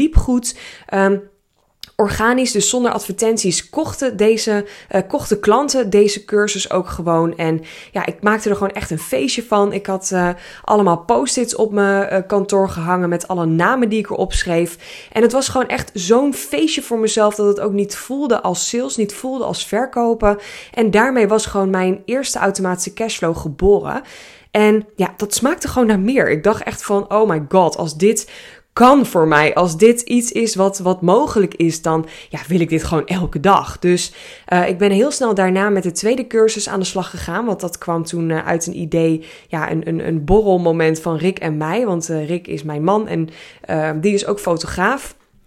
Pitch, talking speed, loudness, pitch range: 200 Hz, 200 wpm, -17 LUFS, 175-220 Hz